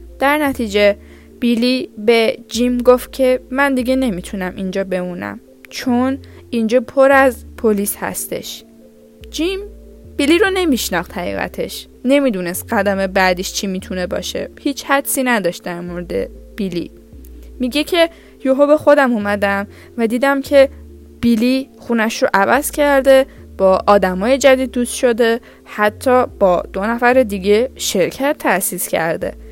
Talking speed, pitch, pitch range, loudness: 125 wpm, 240 Hz, 200-270 Hz, -16 LUFS